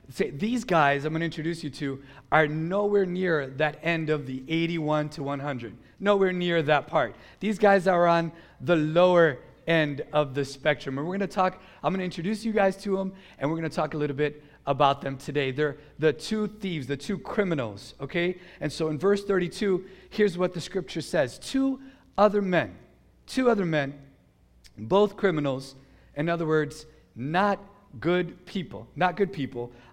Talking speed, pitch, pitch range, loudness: 185 wpm, 165 Hz, 145-190 Hz, -27 LUFS